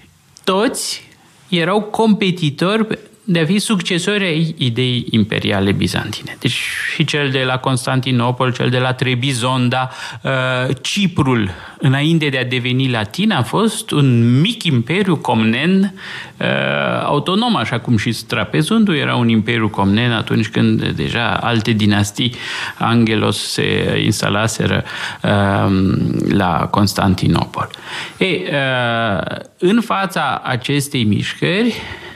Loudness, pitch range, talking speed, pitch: -16 LUFS, 115-170 Hz, 105 wpm, 130 Hz